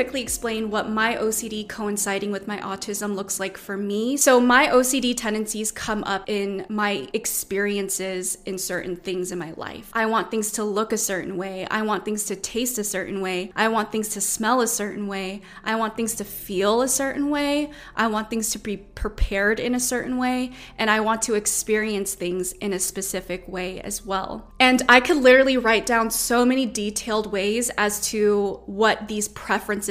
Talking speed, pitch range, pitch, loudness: 195 wpm, 195-225 Hz, 210 Hz, -23 LUFS